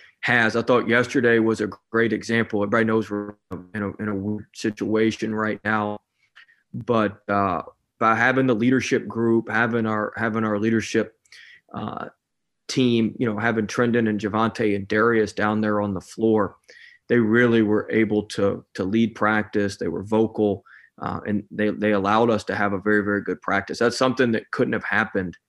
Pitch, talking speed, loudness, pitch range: 110 Hz, 175 wpm, -22 LUFS, 105-115 Hz